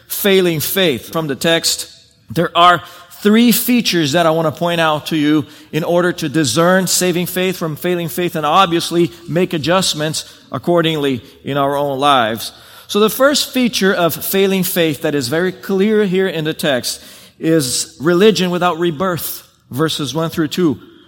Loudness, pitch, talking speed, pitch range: -15 LUFS, 170 Hz, 165 wpm, 155-185 Hz